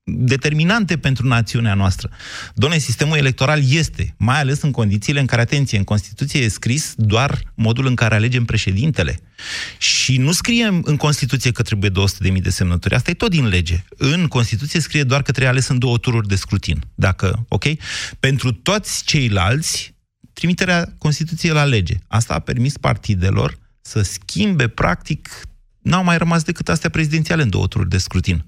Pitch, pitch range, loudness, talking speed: 125 Hz, 105-150 Hz, -17 LUFS, 170 wpm